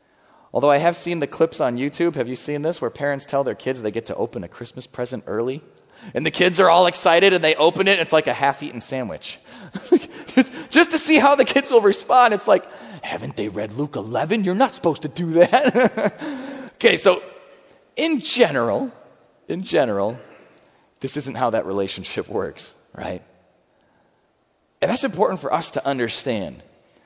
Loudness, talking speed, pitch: -20 LUFS, 185 wpm, 170 Hz